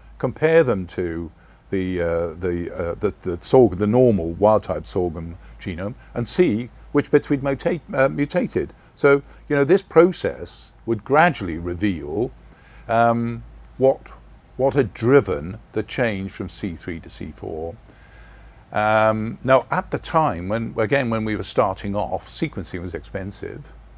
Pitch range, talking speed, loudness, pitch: 90-135 Hz, 145 wpm, -21 LUFS, 110 Hz